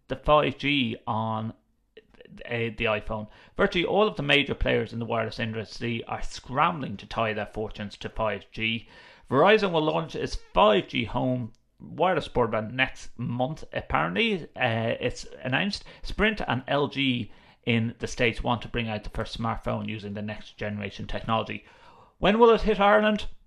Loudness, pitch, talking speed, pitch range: -26 LUFS, 115 Hz, 155 wpm, 110-140 Hz